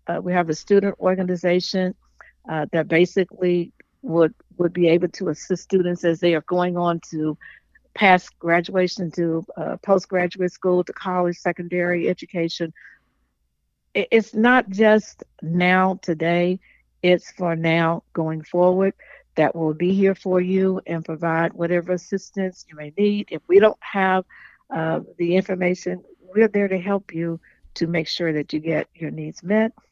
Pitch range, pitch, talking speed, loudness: 165-190 Hz, 180 Hz, 150 wpm, -21 LUFS